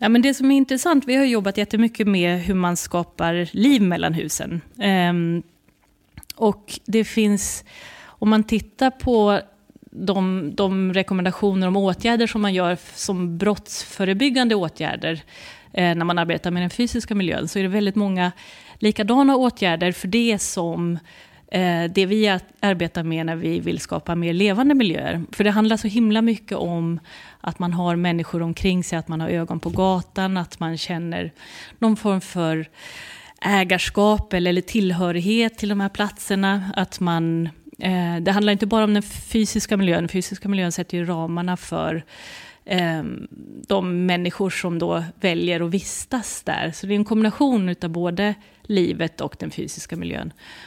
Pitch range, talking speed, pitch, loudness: 175-215 Hz, 155 wpm, 190 Hz, -21 LUFS